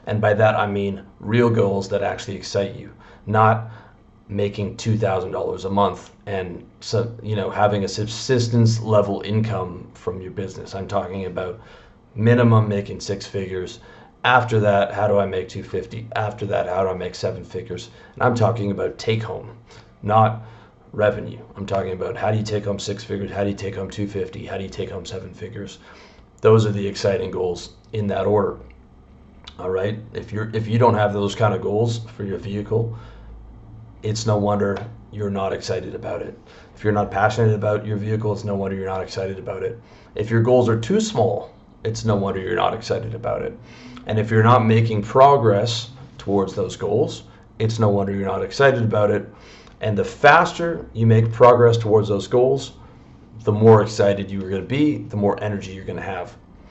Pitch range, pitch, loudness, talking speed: 100-115 Hz, 105 Hz, -21 LUFS, 195 wpm